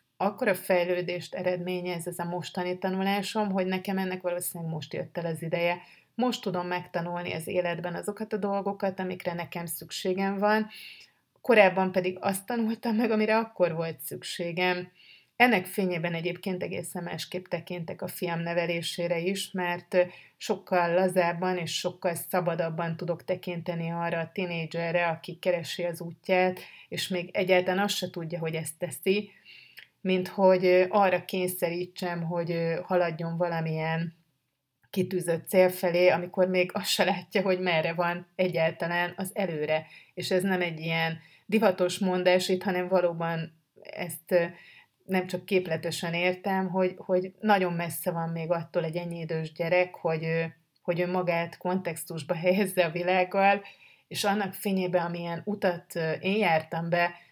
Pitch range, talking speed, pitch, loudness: 170-185 Hz, 140 wpm, 180 Hz, -28 LUFS